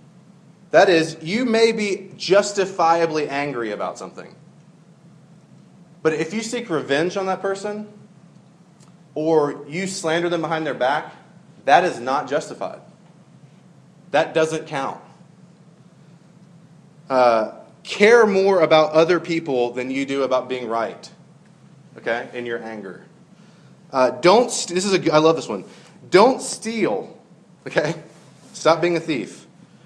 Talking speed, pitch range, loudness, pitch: 130 wpm, 155-180 Hz, -20 LUFS, 170 Hz